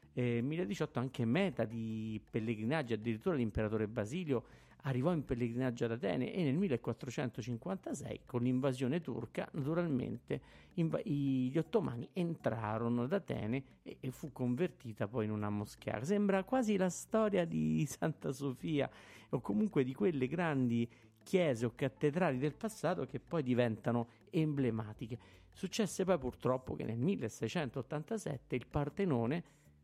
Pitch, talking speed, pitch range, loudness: 130 Hz, 130 wpm, 115-165 Hz, -37 LUFS